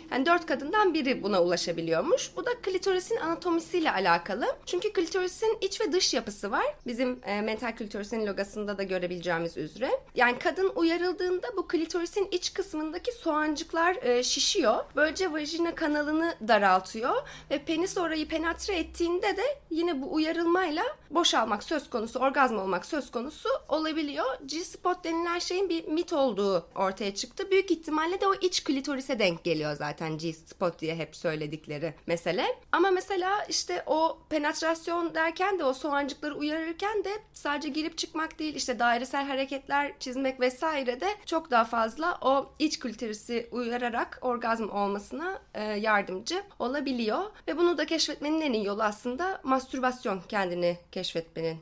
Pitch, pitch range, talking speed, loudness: 295 Hz, 225-345 Hz, 140 wpm, -29 LUFS